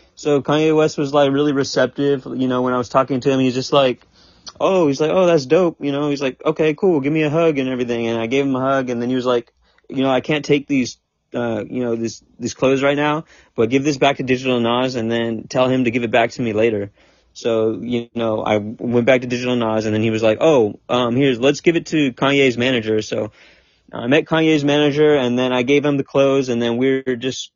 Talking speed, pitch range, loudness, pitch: 260 wpm, 120-145 Hz, -18 LUFS, 130 Hz